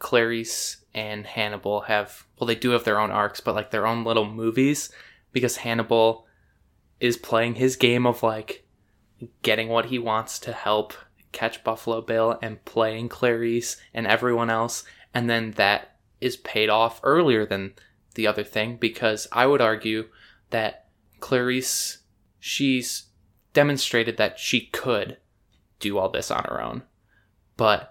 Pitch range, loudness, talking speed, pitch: 105-120 Hz, -24 LUFS, 150 wpm, 115 Hz